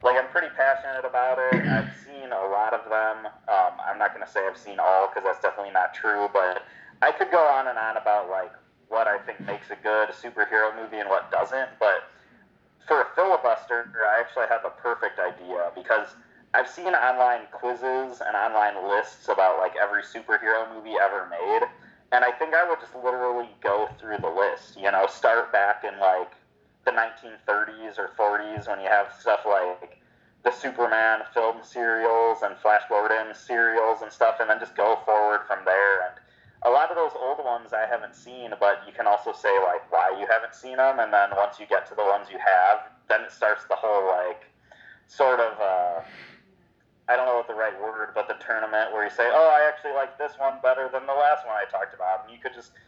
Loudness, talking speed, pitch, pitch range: -24 LUFS, 210 wpm, 115 Hz, 105-130 Hz